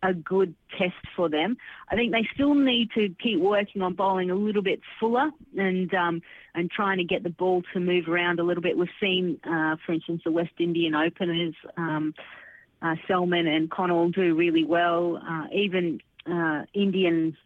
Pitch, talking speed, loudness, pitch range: 175 Hz, 185 wpm, -26 LUFS, 170-195 Hz